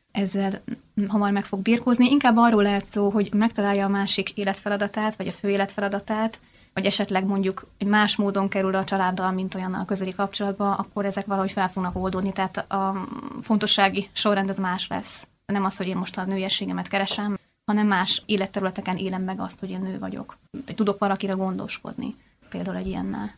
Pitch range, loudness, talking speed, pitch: 190-210 Hz, -24 LUFS, 175 wpm, 200 Hz